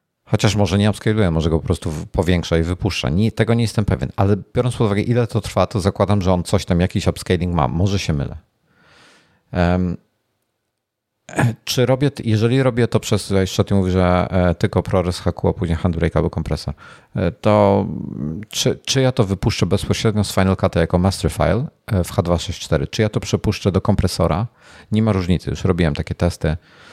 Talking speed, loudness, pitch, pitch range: 185 wpm, -19 LUFS, 100 Hz, 90-110 Hz